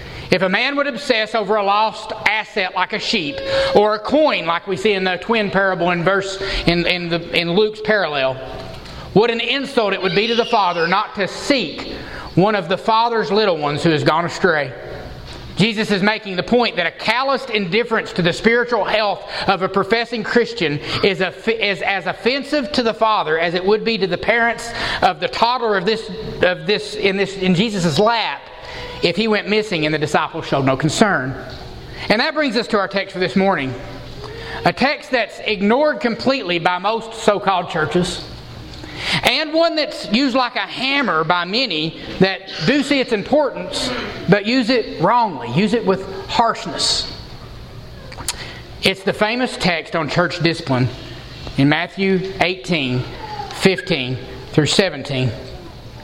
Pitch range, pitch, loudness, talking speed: 175-225 Hz, 195 Hz, -18 LUFS, 170 wpm